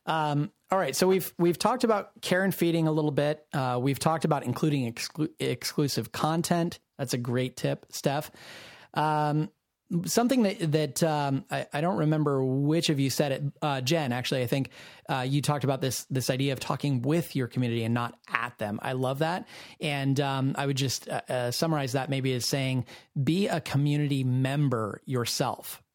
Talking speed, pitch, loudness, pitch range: 190 wpm, 140 Hz, -28 LUFS, 130-160 Hz